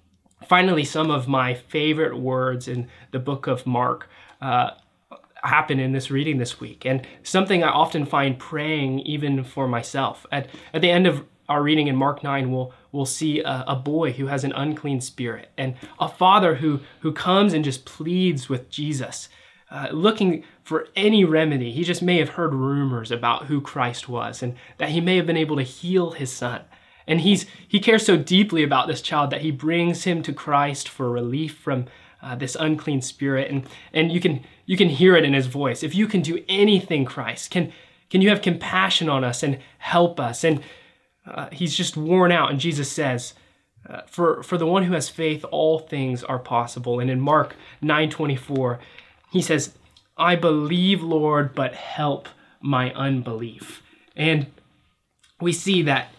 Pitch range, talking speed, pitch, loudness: 135-170 Hz, 185 wpm, 150 Hz, -22 LUFS